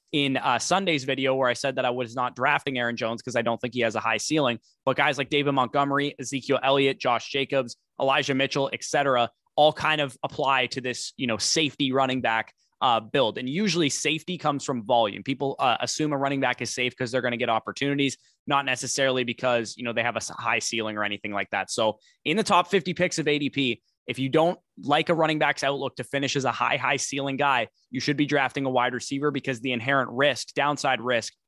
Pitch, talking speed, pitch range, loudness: 135 Hz, 225 wpm, 125-145 Hz, -25 LUFS